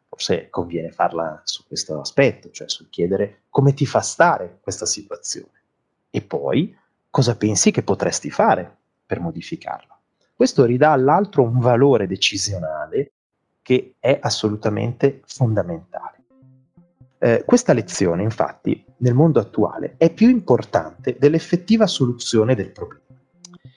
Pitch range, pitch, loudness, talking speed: 115-160 Hz, 130 Hz, -19 LUFS, 120 wpm